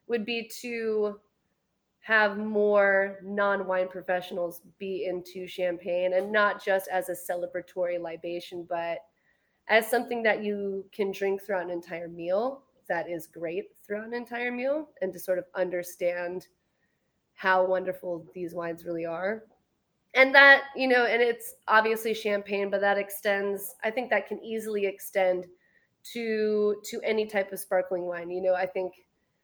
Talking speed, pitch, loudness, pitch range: 150 wpm, 195 Hz, -27 LUFS, 180-220 Hz